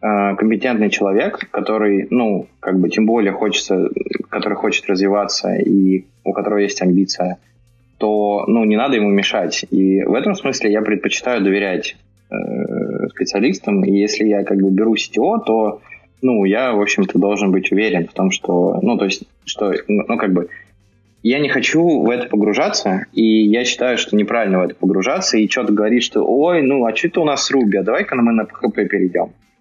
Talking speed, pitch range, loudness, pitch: 180 wpm, 100-110 Hz, -16 LUFS, 105 Hz